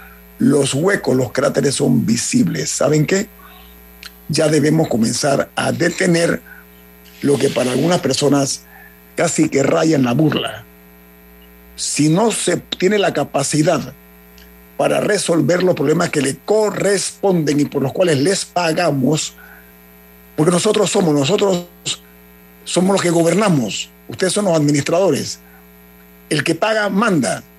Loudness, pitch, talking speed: -16 LUFS, 145 Hz, 130 wpm